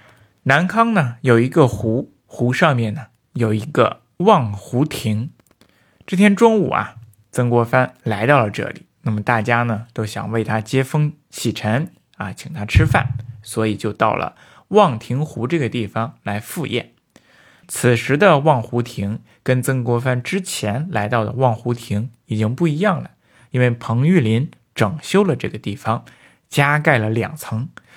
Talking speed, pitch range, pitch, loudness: 225 characters per minute, 110-145 Hz, 120 Hz, -19 LUFS